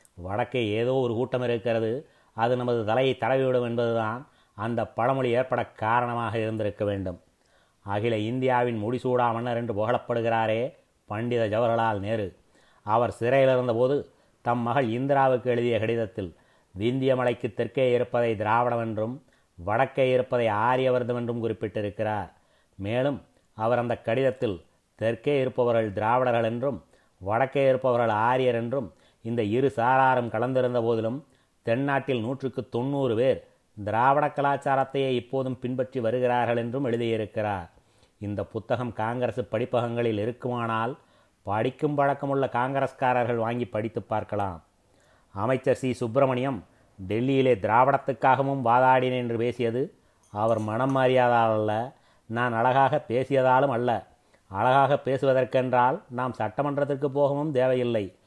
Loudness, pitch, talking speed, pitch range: -26 LUFS, 120 Hz, 105 wpm, 110-130 Hz